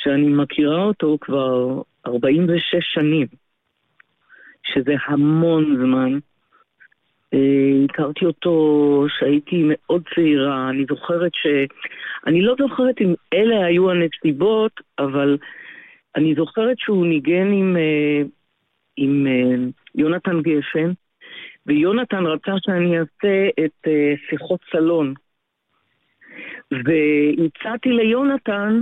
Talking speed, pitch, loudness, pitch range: 90 wpm, 155 Hz, -19 LUFS, 145-185 Hz